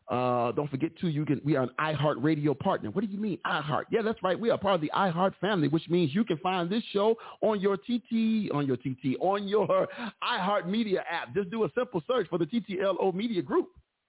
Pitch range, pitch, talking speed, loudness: 155-215 Hz, 185 Hz, 230 wpm, -29 LUFS